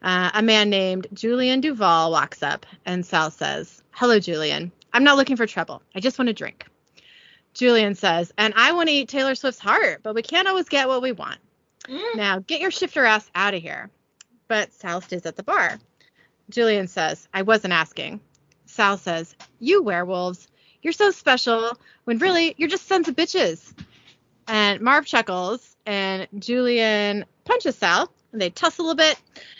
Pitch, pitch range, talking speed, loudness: 225 Hz, 190-270 Hz, 175 wpm, -21 LUFS